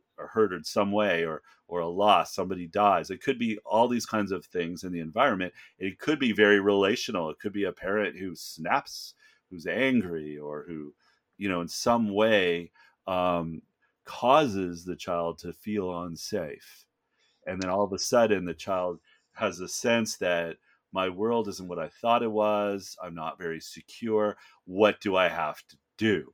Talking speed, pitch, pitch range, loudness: 180 wpm, 95 Hz, 85-105 Hz, -28 LUFS